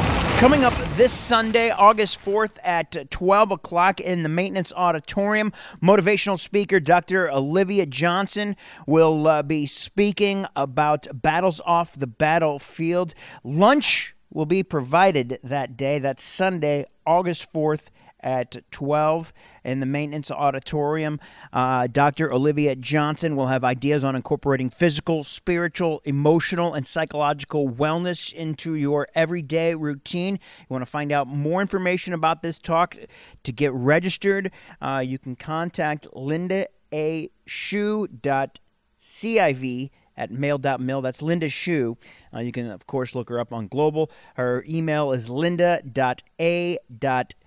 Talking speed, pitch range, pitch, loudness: 135 wpm, 140-175 Hz, 155 Hz, -22 LUFS